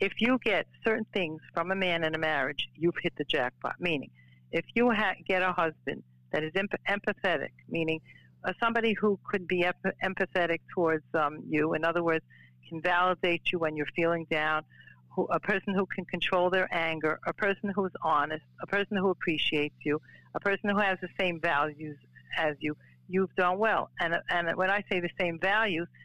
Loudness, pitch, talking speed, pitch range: -30 LUFS, 175 Hz, 195 wpm, 155-195 Hz